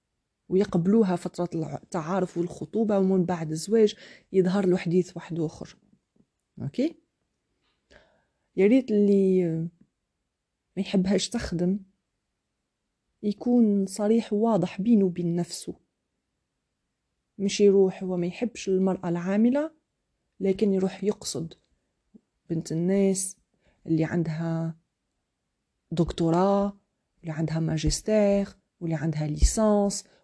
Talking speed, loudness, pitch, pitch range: 90 wpm, -26 LUFS, 190 Hz, 170-205 Hz